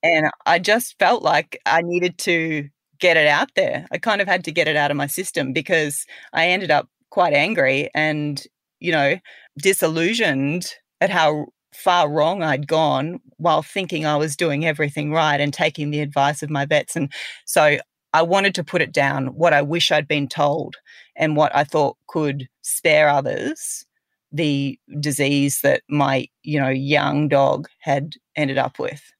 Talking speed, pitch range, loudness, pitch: 175 wpm, 145-170 Hz, -19 LUFS, 150 Hz